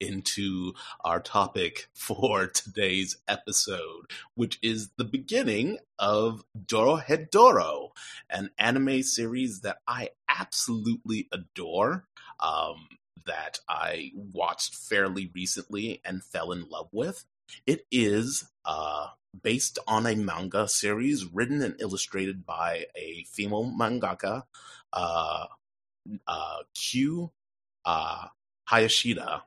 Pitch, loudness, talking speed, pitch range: 110 Hz, -28 LUFS, 100 wpm, 95-130 Hz